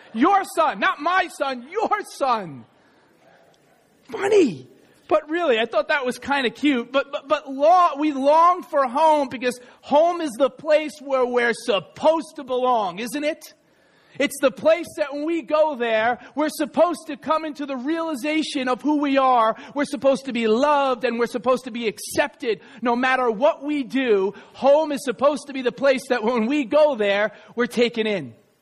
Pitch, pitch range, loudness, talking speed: 280 Hz, 245-305 Hz, -21 LUFS, 180 wpm